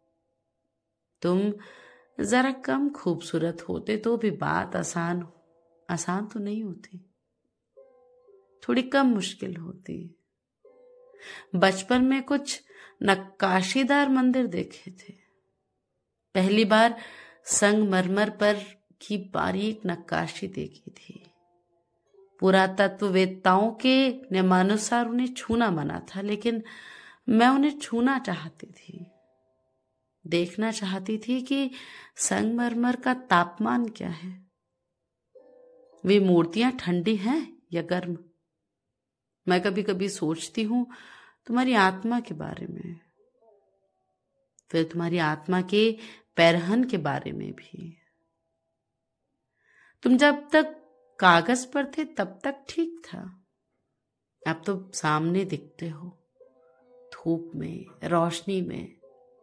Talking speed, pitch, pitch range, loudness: 100 wpm, 195 Hz, 170-245 Hz, -26 LUFS